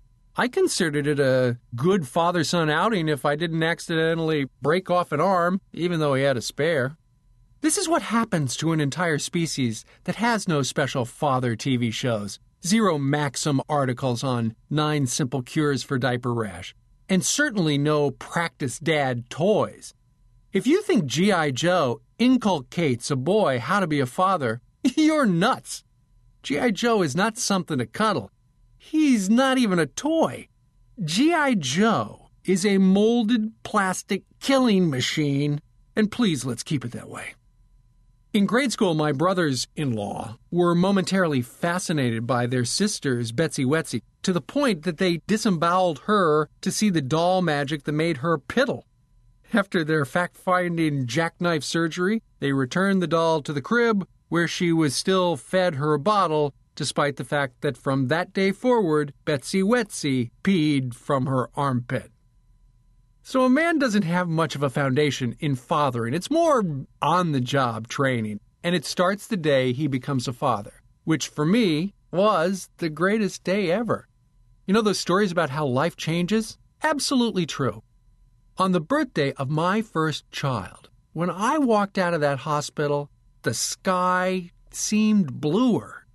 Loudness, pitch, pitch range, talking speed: -23 LUFS, 155 Hz, 130-190 Hz, 155 wpm